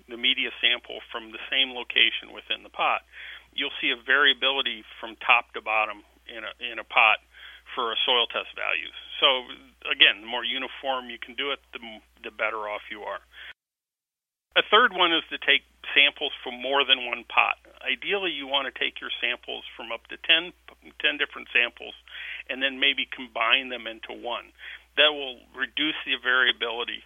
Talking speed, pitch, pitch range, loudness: 180 wpm, 130 Hz, 120-140 Hz, -24 LUFS